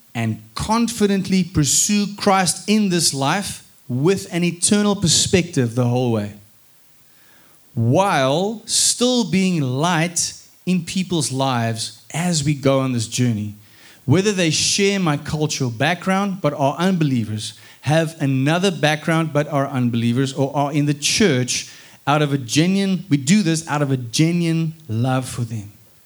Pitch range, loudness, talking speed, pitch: 130-180 Hz, -19 LUFS, 140 wpm, 150 Hz